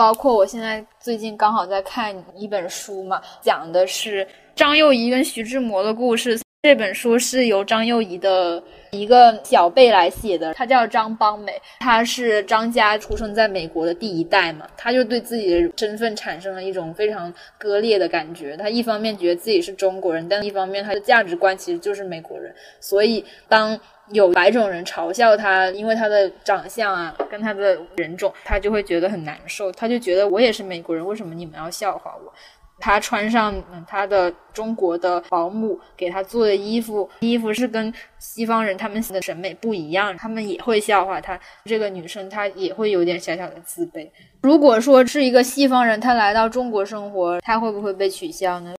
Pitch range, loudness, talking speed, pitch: 185-225 Hz, -19 LUFS, 290 characters per minute, 205 Hz